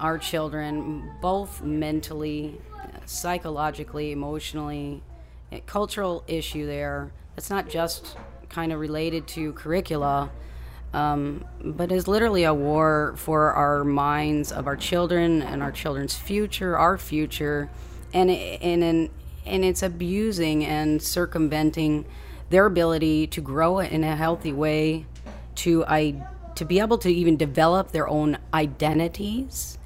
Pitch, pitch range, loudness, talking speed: 155 Hz, 150-175 Hz, -25 LUFS, 125 wpm